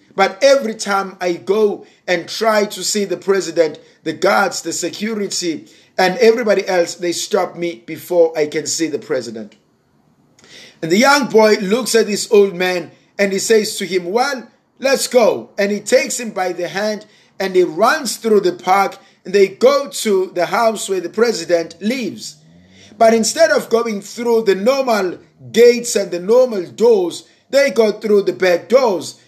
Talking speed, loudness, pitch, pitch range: 175 wpm, -16 LUFS, 200 Hz, 175-225 Hz